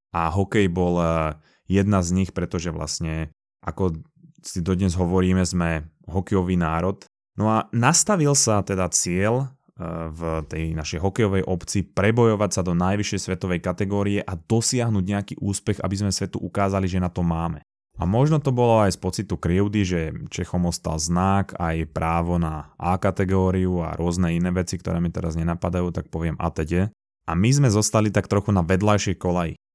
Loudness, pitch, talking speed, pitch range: -23 LUFS, 95 Hz, 170 wpm, 85-100 Hz